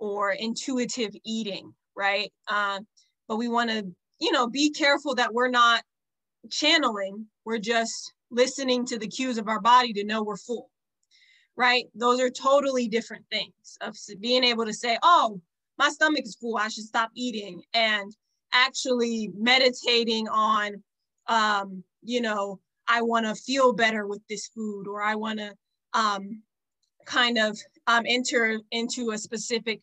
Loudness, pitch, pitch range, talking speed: -25 LUFS, 230 Hz, 210-245 Hz, 155 wpm